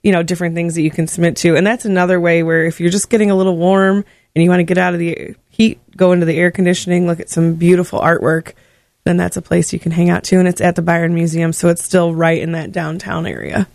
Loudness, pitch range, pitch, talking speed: -14 LUFS, 165-180 Hz, 175 Hz, 280 wpm